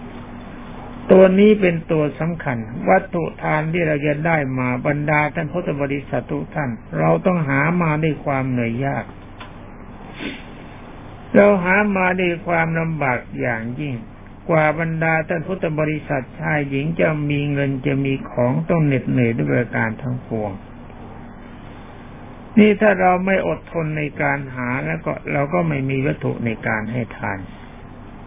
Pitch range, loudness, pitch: 125-165 Hz, -19 LUFS, 145 Hz